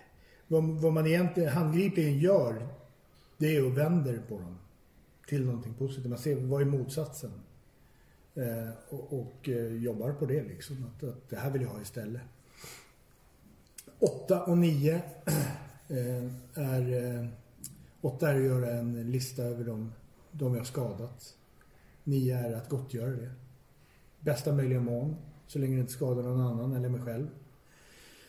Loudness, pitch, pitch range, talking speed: -32 LUFS, 130 Hz, 120-145 Hz, 145 wpm